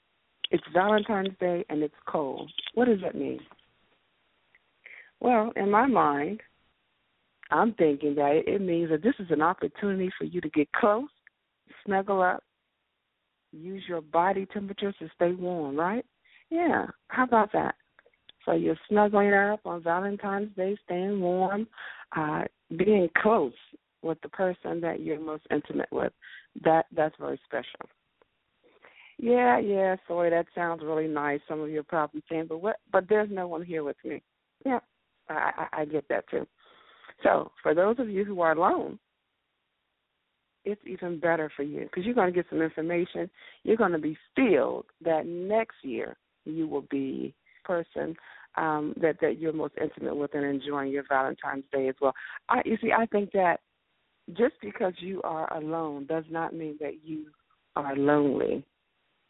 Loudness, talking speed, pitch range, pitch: -28 LUFS, 160 wpm, 155-205 Hz, 175 Hz